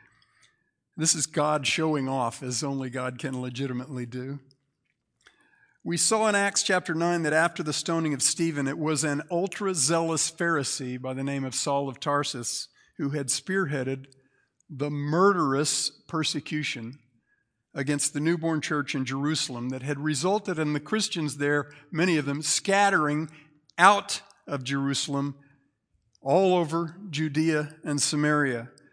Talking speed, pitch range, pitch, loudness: 140 wpm, 135-165 Hz, 145 Hz, -26 LUFS